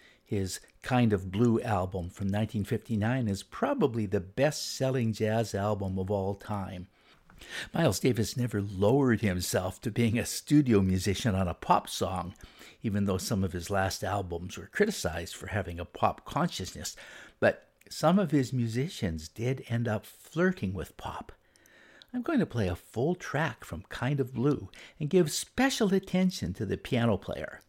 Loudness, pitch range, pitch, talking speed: -30 LUFS, 95-130 Hz, 110 Hz, 165 wpm